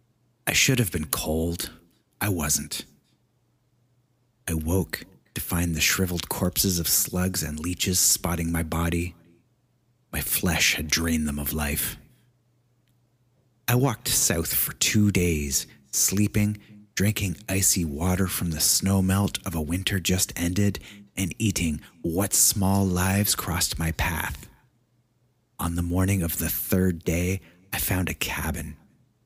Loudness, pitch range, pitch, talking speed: -24 LUFS, 85-105 Hz, 95 Hz, 135 wpm